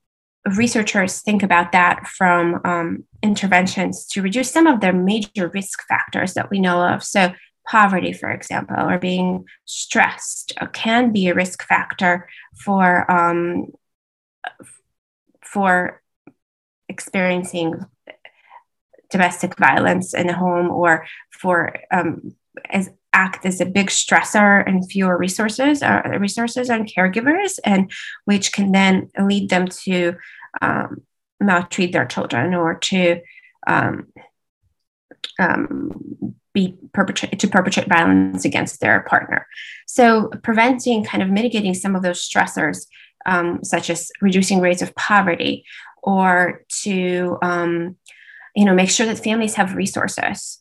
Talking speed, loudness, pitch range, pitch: 125 wpm, -18 LUFS, 175-205 Hz, 185 Hz